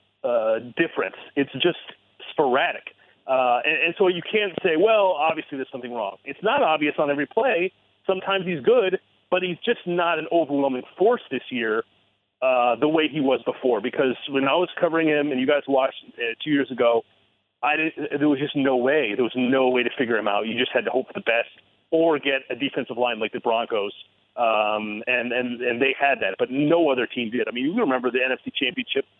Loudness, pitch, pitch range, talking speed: -23 LUFS, 140 Hz, 125-170 Hz, 215 wpm